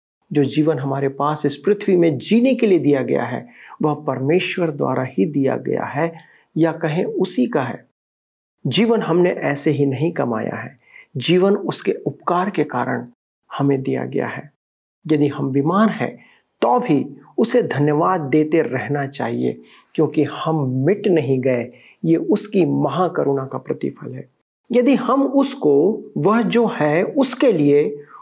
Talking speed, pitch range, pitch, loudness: 150 wpm, 140-185 Hz, 155 Hz, -19 LUFS